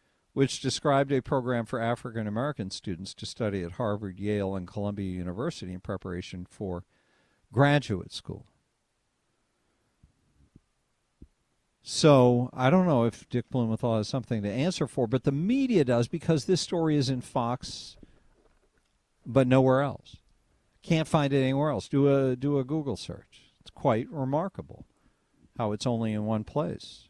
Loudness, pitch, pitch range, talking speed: -28 LUFS, 125 Hz, 105-140 Hz, 145 wpm